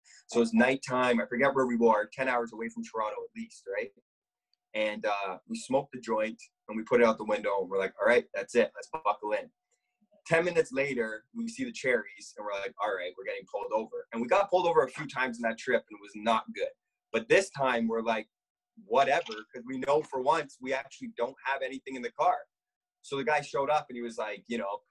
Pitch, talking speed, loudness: 150 Hz, 245 wpm, -30 LUFS